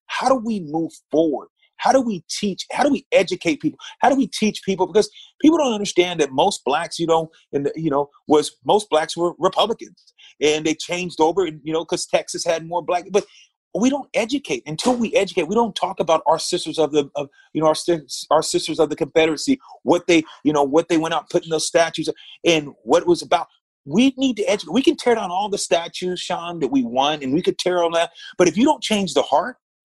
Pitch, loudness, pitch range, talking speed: 175 Hz, -20 LUFS, 160-220 Hz, 235 wpm